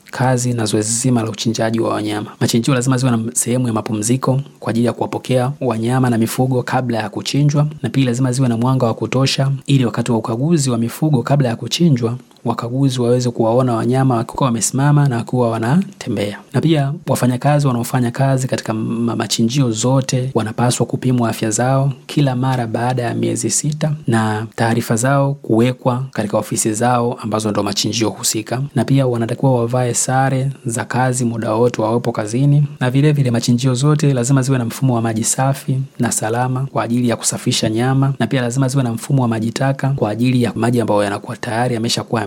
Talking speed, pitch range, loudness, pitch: 180 wpm, 115-135 Hz, -17 LUFS, 125 Hz